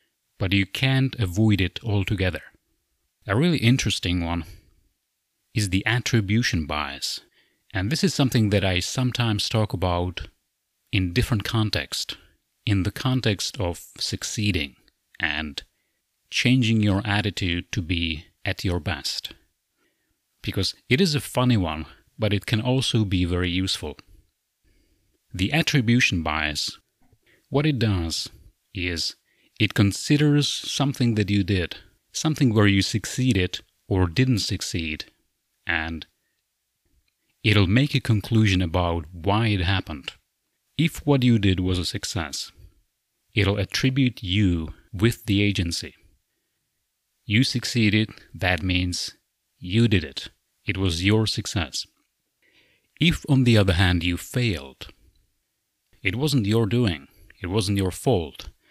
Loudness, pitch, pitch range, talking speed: -23 LUFS, 100 Hz, 90-115 Hz, 125 wpm